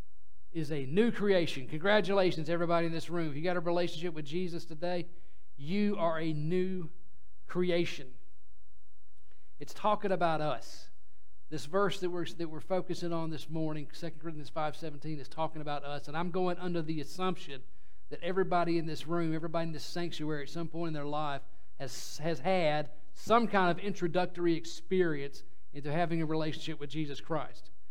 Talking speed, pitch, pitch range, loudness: 170 wpm, 165 Hz, 150-175 Hz, -34 LUFS